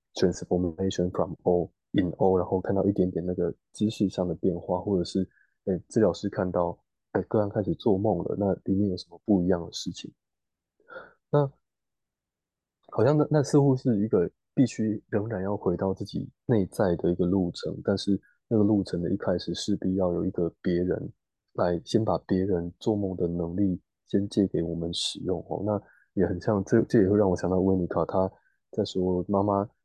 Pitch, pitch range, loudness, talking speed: 95 Hz, 90-105 Hz, -27 LUFS, 300 characters per minute